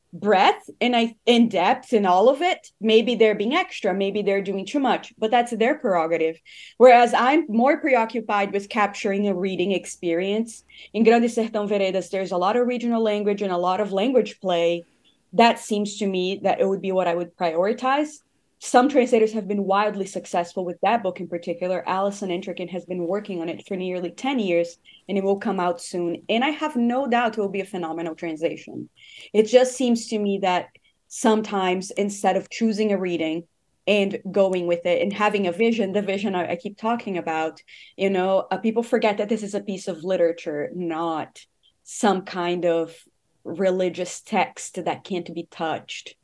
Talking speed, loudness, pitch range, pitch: 190 wpm, -22 LUFS, 180-225 Hz, 195 Hz